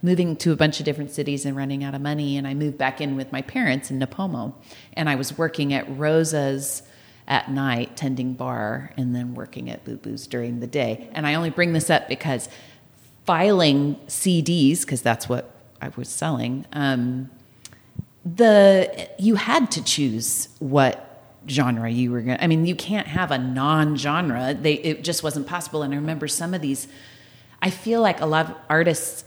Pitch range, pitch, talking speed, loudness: 130-160 Hz, 145 Hz, 190 wpm, -22 LUFS